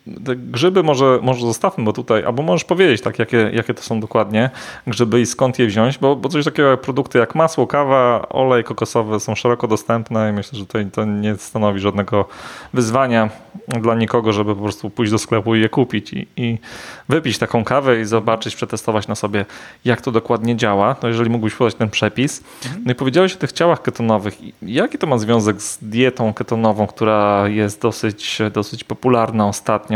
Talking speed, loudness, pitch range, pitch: 190 wpm, -17 LUFS, 110-125 Hz, 115 Hz